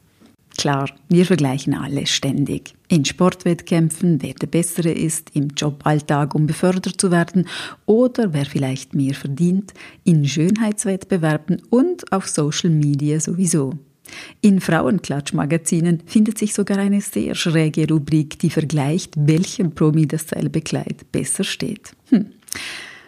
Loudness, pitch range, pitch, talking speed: -19 LUFS, 150-190 Hz, 165 Hz, 120 wpm